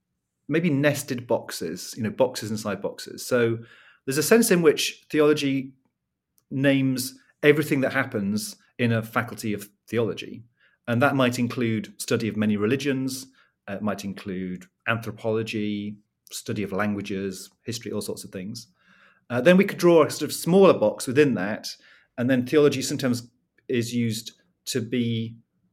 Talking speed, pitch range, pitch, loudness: 150 wpm, 105-140 Hz, 120 Hz, -24 LUFS